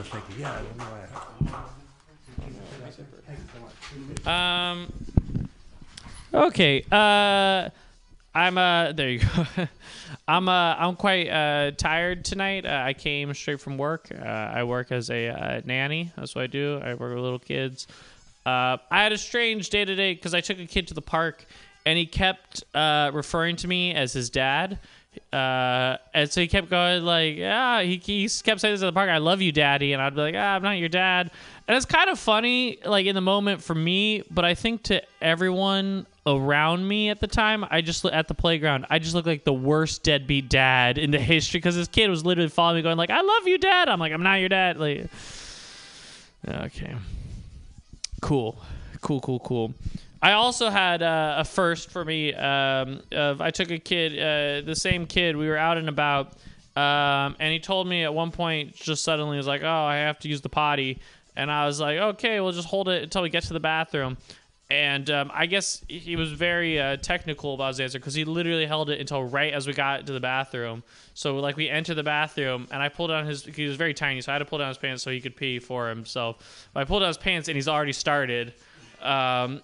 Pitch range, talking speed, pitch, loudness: 140-180 Hz, 210 wpm, 155 Hz, -24 LUFS